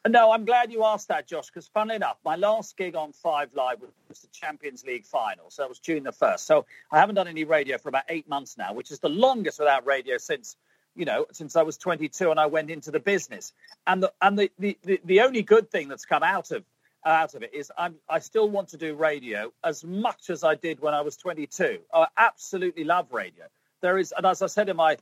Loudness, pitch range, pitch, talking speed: -25 LUFS, 155-205 Hz, 175 Hz, 250 wpm